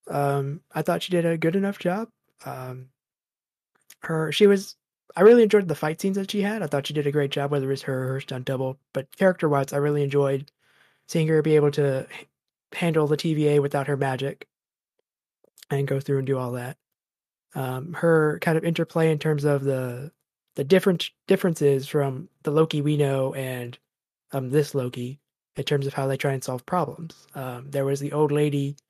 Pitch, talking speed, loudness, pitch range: 145 Hz, 200 wpm, -24 LUFS, 135-160 Hz